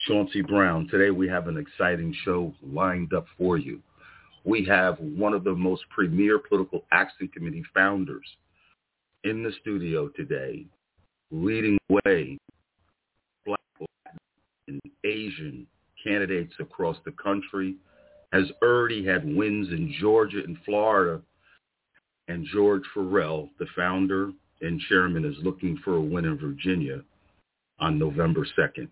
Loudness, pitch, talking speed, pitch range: -26 LUFS, 100 Hz, 130 wpm, 95-140 Hz